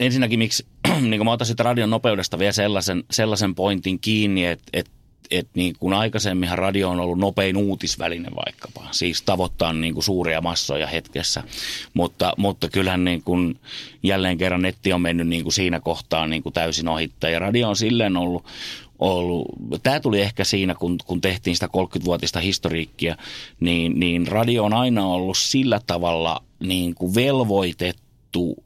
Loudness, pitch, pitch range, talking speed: -22 LUFS, 95 Hz, 85-105 Hz, 160 wpm